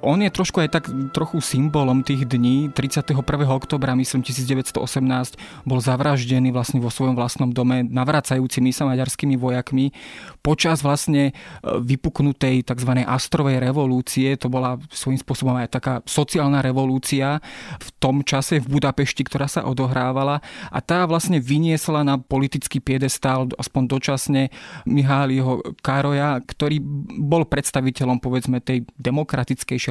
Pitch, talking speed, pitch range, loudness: 135 Hz, 125 wpm, 130-145 Hz, -21 LUFS